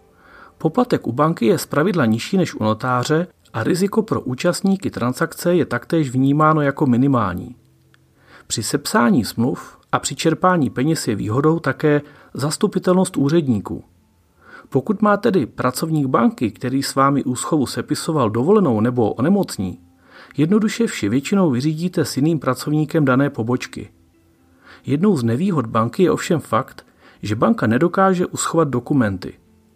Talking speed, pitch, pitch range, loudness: 130 wpm, 140 Hz, 115-165 Hz, -19 LUFS